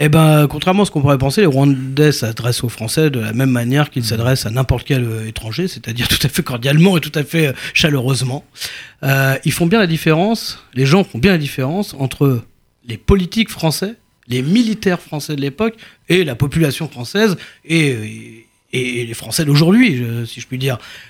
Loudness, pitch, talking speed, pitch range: -16 LUFS, 140 Hz, 195 wpm, 125-165 Hz